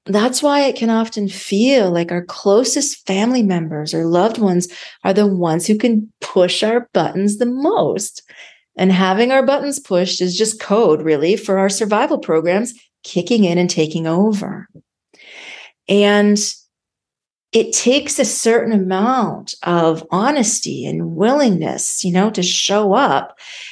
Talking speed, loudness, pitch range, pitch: 145 wpm, -16 LUFS, 180-240 Hz, 205 Hz